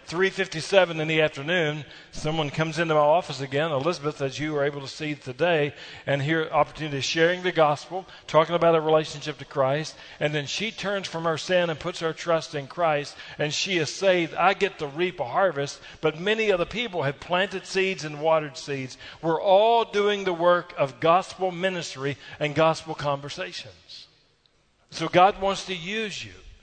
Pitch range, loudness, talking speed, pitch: 150-180 Hz, -25 LUFS, 185 wpm, 160 Hz